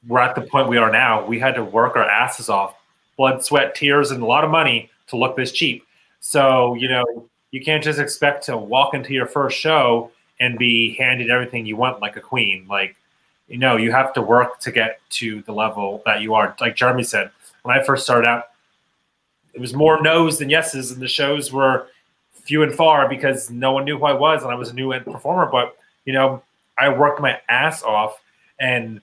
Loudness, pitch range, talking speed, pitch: -18 LUFS, 115-140 Hz, 220 wpm, 125 Hz